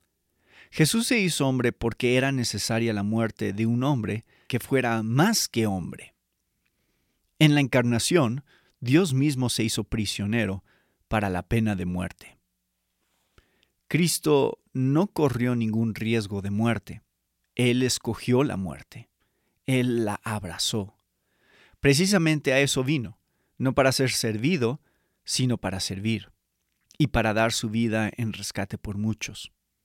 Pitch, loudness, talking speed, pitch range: 115 Hz, -25 LUFS, 130 wpm, 105-135 Hz